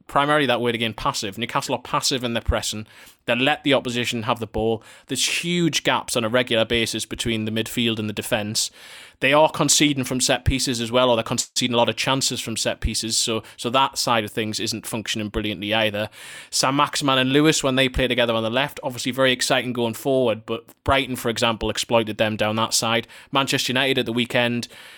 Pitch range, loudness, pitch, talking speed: 110-130 Hz, -21 LUFS, 120 Hz, 210 wpm